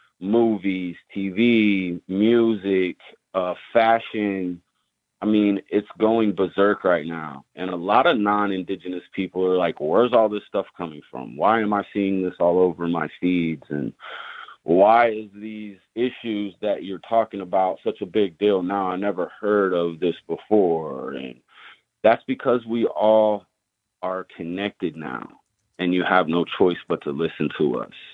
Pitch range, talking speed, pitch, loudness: 90-105 Hz, 155 wpm, 100 Hz, -22 LUFS